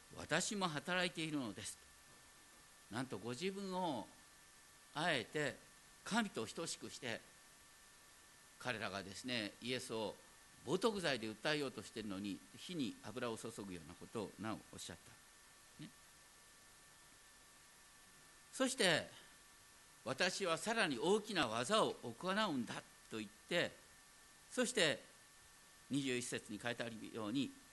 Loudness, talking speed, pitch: -41 LUFS, 235 characters per minute, 135 Hz